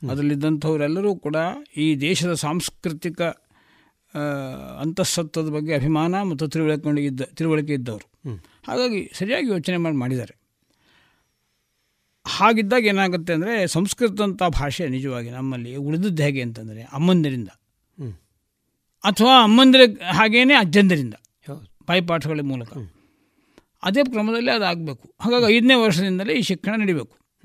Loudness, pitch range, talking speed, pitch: -20 LUFS, 140-195 Hz, 95 wpm, 160 Hz